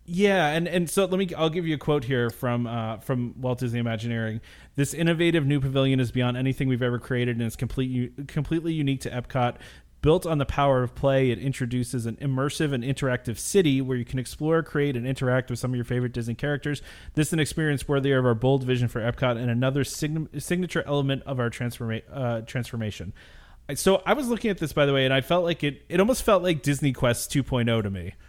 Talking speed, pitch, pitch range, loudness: 225 wpm, 135 Hz, 120-150 Hz, -25 LUFS